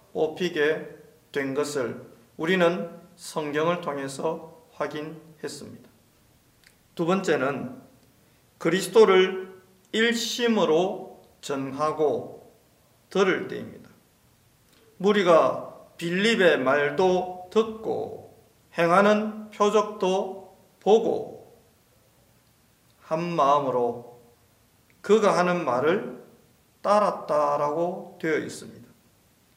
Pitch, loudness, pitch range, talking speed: 170 Hz, -24 LUFS, 150-190 Hz, 170 characters per minute